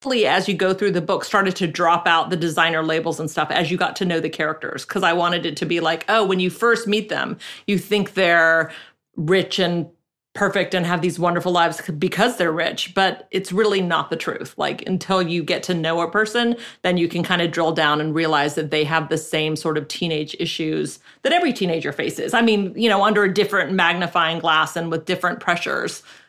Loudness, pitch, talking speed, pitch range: -20 LUFS, 175 Hz, 225 wpm, 165-190 Hz